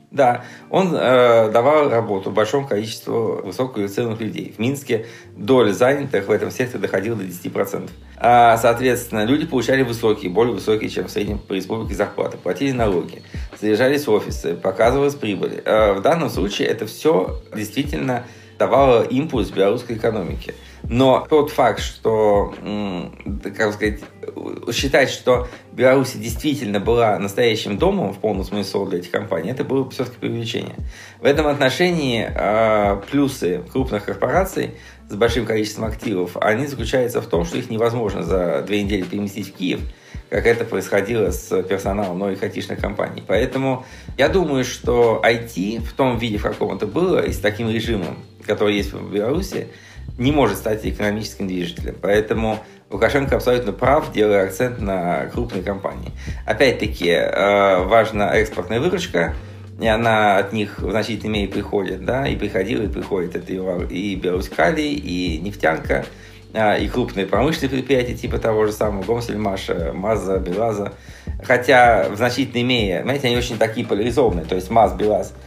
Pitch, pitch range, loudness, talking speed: 110 Hz, 100-125 Hz, -19 LUFS, 145 wpm